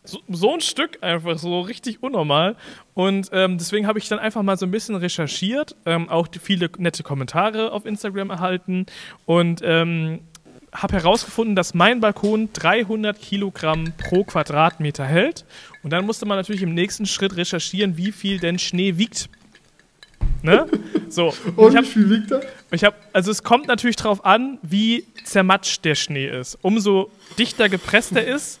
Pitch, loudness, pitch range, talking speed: 195 Hz, -20 LUFS, 175-215 Hz, 155 wpm